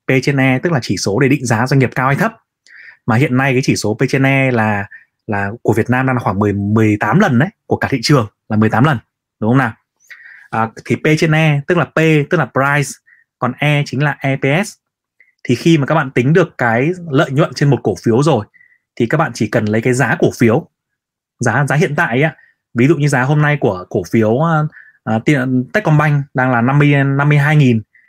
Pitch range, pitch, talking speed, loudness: 120-150 Hz, 135 Hz, 210 wpm, -14 LUFS